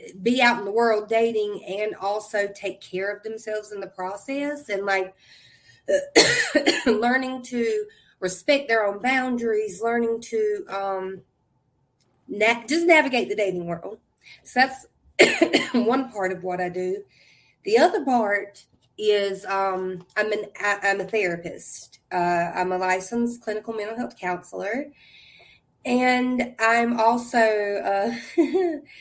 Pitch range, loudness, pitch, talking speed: 190-250 Hz, -23 LUFS, 215 Hz, 130 wpm